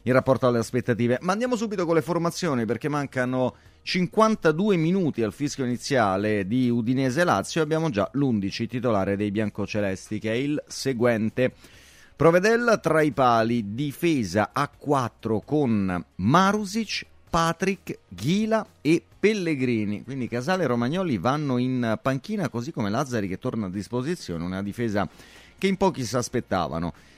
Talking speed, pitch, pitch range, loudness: 140 wpm, 125 Hz, 110-165 Hz, -25 LUFS